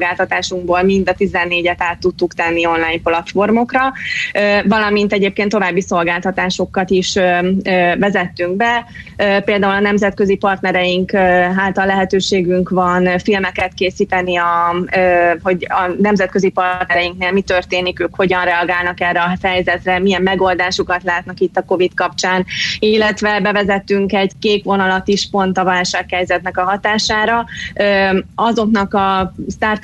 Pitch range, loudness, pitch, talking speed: 180-200 Hz, -15 LUFS, 185 Hz, 115 wpm